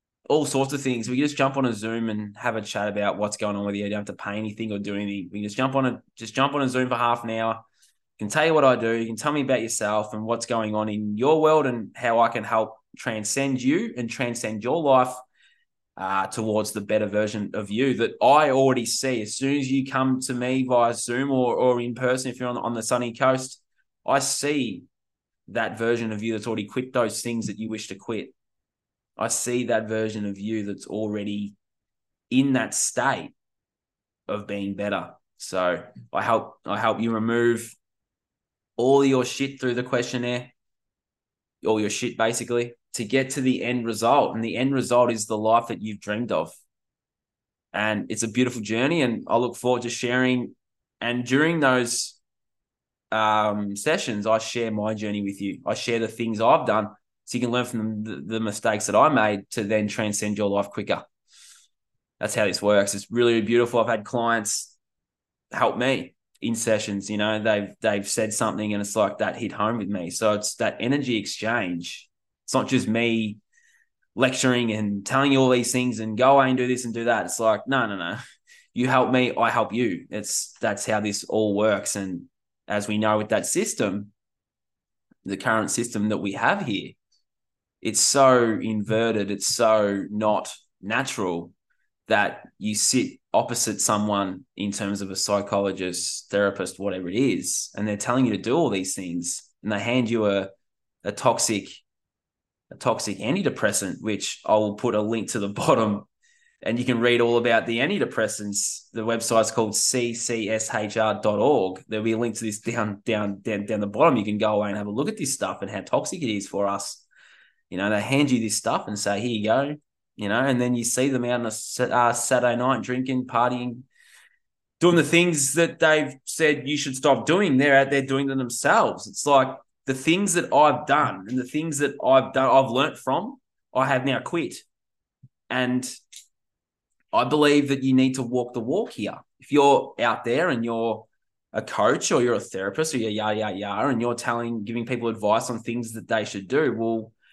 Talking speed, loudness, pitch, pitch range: 200 wpm, -24 LUFS, 115 Hz, 105-125 Hz